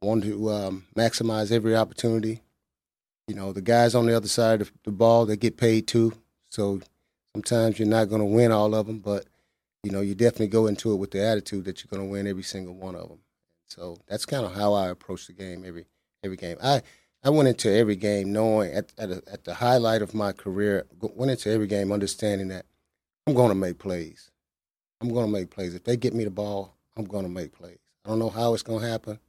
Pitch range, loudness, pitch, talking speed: 95-115 Hz, -25 LUFS, 105 Hz, 235 wpm